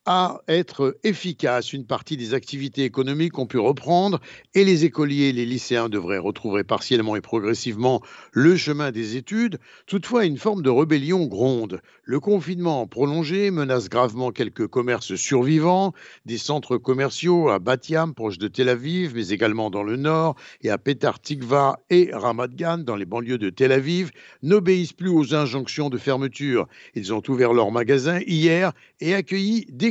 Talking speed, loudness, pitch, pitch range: 165 wpm, -22 LUFS, 140 Hz, 125-170 Hz